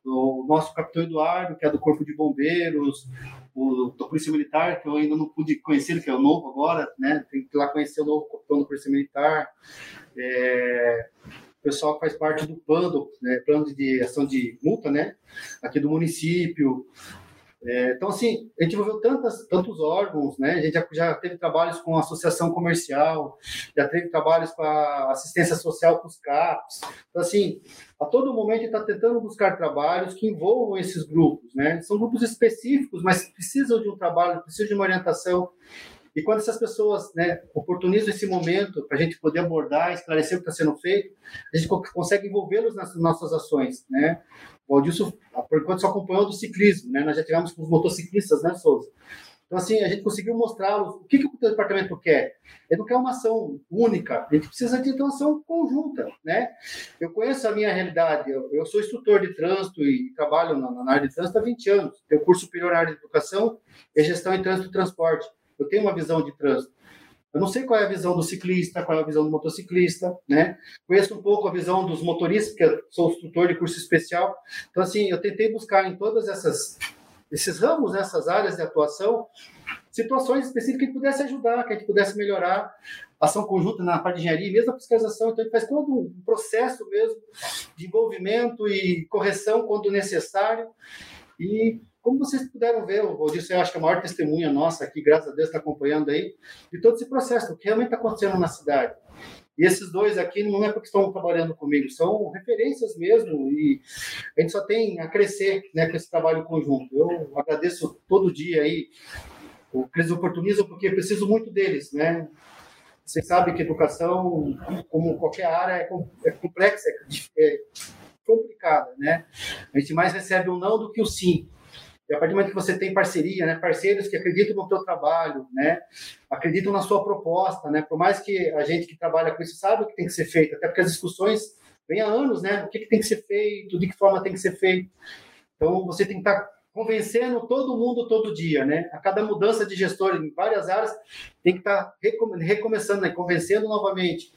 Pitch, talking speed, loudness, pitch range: 185 Hz, 200 wpm, -24 LUFS, 160-220 Hz